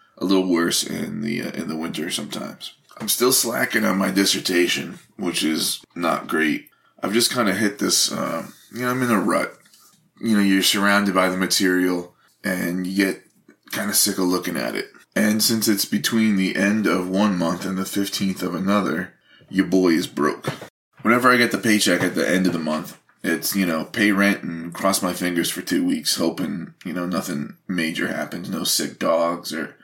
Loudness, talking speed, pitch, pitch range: -21 LUFS, 205 wpm, 95 Hz, 90-105 Hz